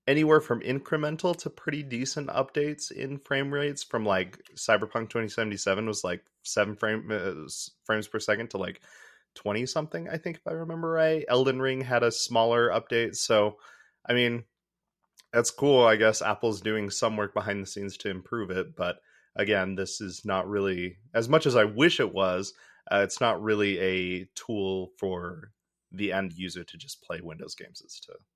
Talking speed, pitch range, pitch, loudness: 180 wpm, 100-140 Hz, 115 Hz, -28 LUFS